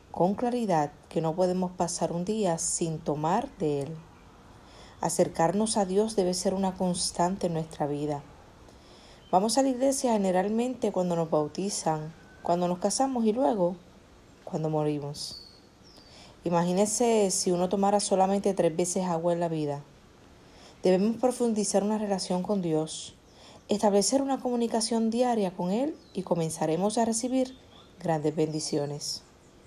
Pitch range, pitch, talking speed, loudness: 160-215 Hz, 185 Hz, 135 wpm, -28 LUFS